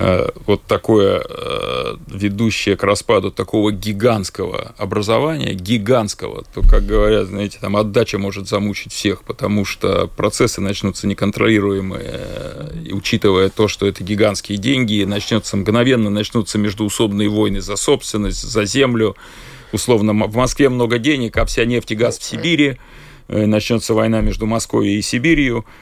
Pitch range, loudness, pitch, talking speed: 100-120 Hz, -17 LUFS, 105 Hz, 130 wpm